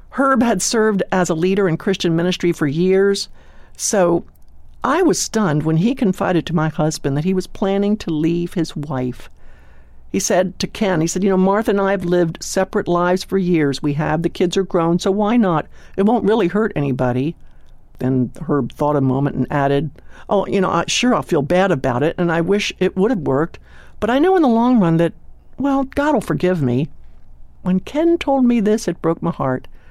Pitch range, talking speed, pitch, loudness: 150-200 Hz, 215 wpm, 180 Hz, -18 LUFS